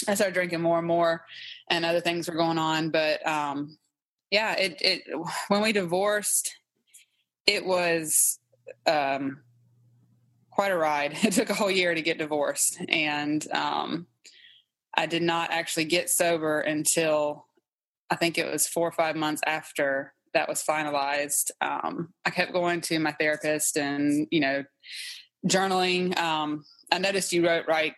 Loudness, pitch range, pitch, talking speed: -26 LUFS, 150-175 Hz, 165 Hz, 155 wpm